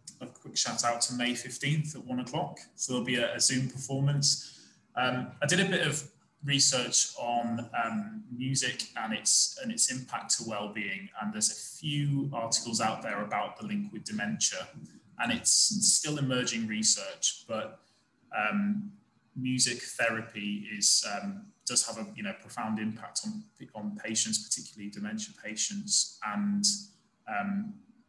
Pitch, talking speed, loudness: 145 Hz, 155 wpm, -30 LUFS